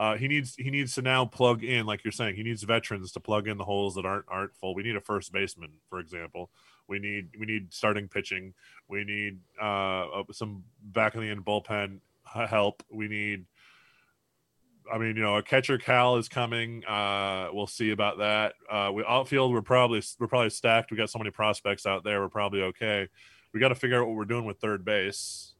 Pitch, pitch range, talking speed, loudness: 105 Hz, 100-115 Hz, 215 wpm, -29 LUFS